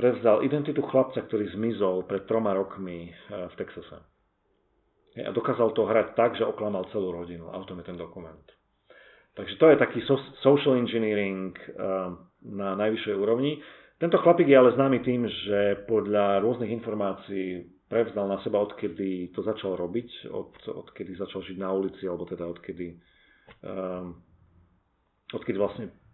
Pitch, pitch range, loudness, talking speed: 100 Hz, 90-115 Hz, -26 LUFS, 140 wpm